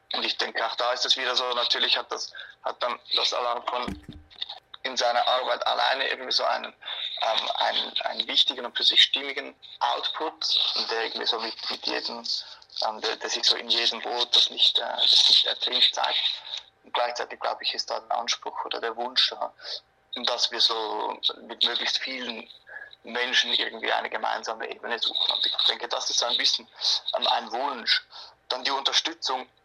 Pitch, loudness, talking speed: 125 Hz, -24 LUFS, 185 wpm